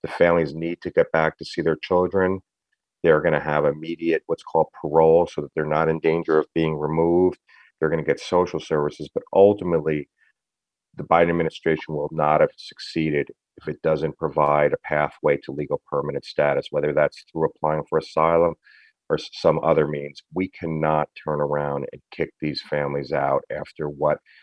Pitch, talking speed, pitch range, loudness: 80 Hz, 180 wpm, 75-85 Hz, -22 LUFS